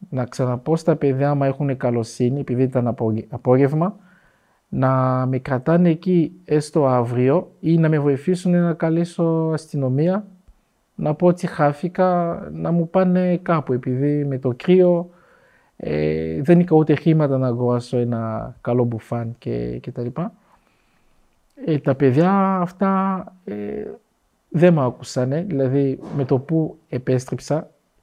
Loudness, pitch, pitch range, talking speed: -20 LUFS, 145 Hz, 125-170 Hz, 135 wpm